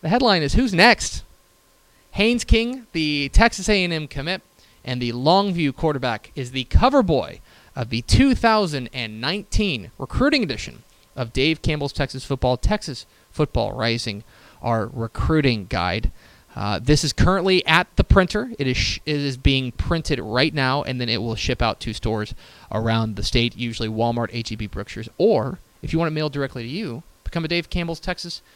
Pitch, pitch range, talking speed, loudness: 135 Hz, 115-165 Hz, 170 wpm, -21 LUFS